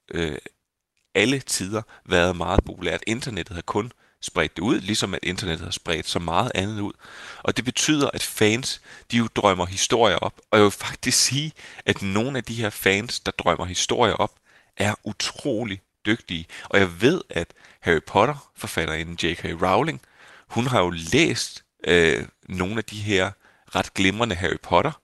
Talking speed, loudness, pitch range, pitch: 170 wpm, -23 LUFS, 90-115 Hz, 100 Hz